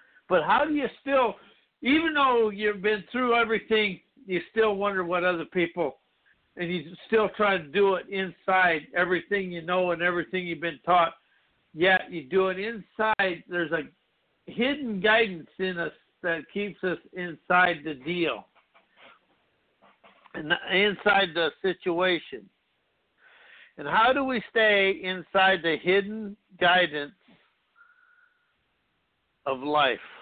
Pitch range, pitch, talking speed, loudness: 175-215 Hz, 190 Hz, 130 wpm, -25 LUFS